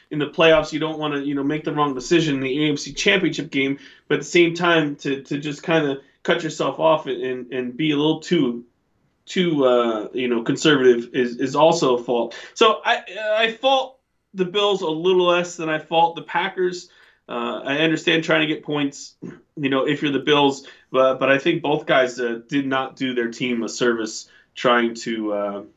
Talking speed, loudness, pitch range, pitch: 210 wpm, -20 LUFS, 130-165 Hz, 145 Hz